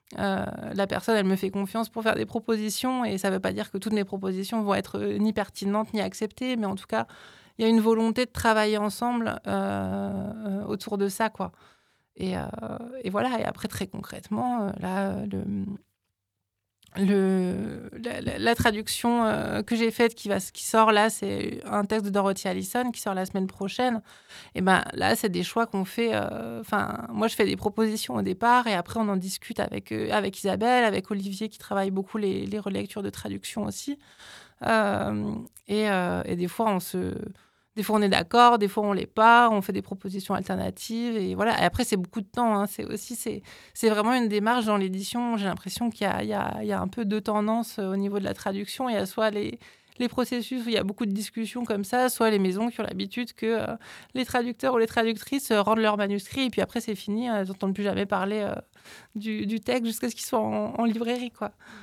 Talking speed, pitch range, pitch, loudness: 225 wpm, 195-230 Hz, 210 Hz, -27 LUFS